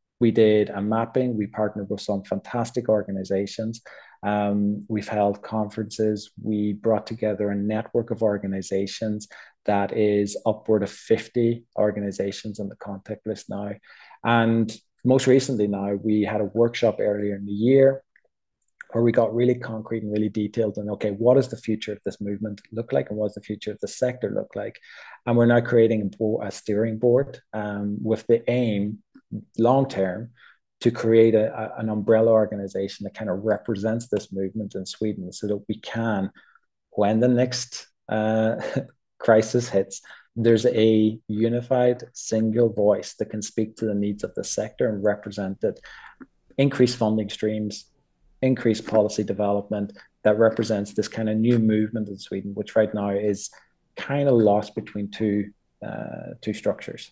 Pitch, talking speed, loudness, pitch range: 110 Hz, 165 wpm, -24 LUFS, 105-115 Hz